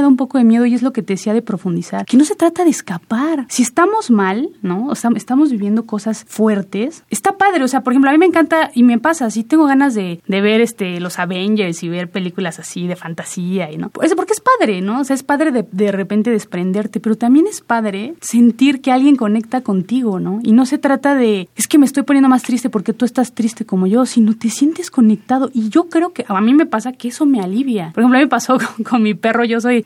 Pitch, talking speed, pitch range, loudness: 235 Hz, 255 wpm, 210-275 Hz, -15 LUFS